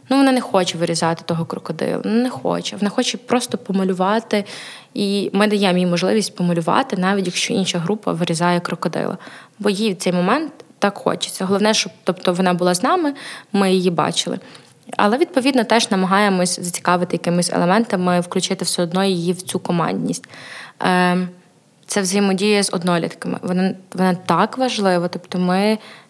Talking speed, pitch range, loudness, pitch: 150 wpm, 180-215 Hz, -19 LUFS, 190 Hz